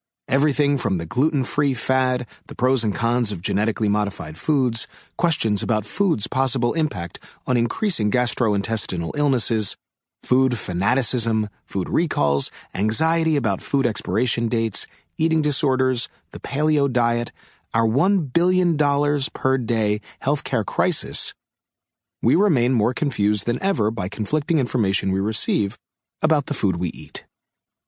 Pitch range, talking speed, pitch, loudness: 105-145 Hz, 125 wpm, 125 Hz, -22 LUFS